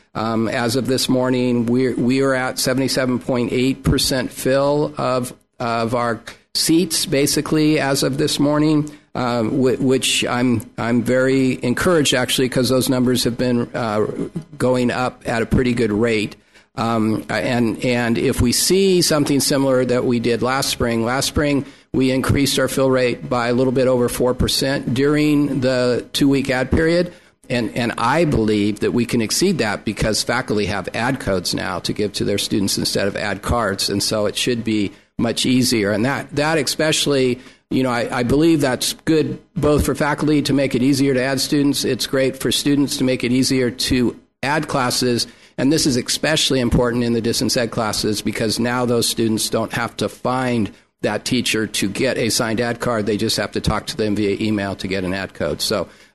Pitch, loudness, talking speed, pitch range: 125 Hz, -18 LUFS, 190 wpm, 120-140 Hz